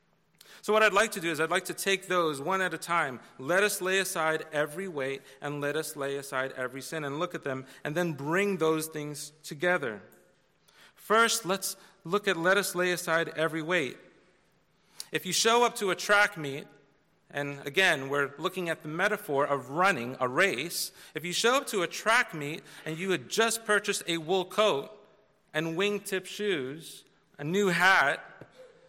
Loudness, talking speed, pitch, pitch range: -28 LUFS, 185 wpm, 175 Hz, 150-195 Hz